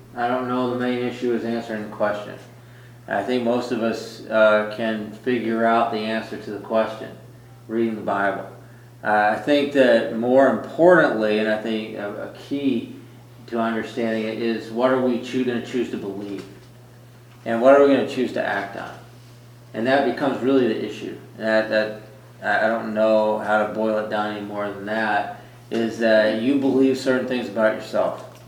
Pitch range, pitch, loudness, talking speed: 110-125 Hz, 115 Hz, -21 LUFS, 190 wpm